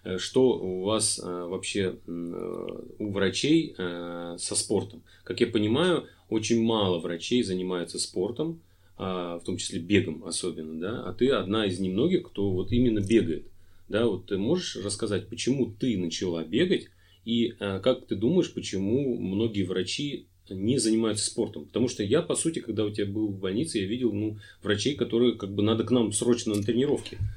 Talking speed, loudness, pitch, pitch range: 170 wpm, -28 LUFS, 105 Hz, 95-115 Hz